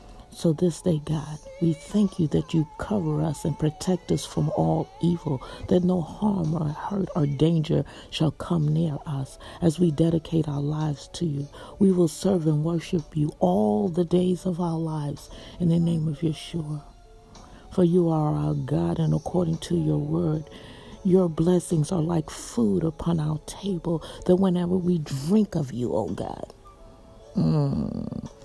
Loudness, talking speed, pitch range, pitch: -25 LUFS, 170 wpm, 150-180 Hz, 165 Hz